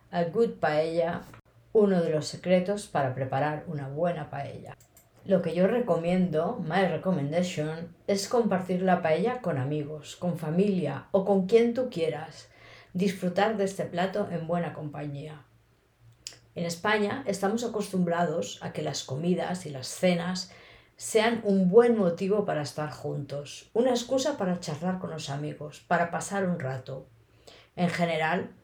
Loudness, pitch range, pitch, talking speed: -28 LUFS, 150-195 Hz, 170 Hz, 145 wpm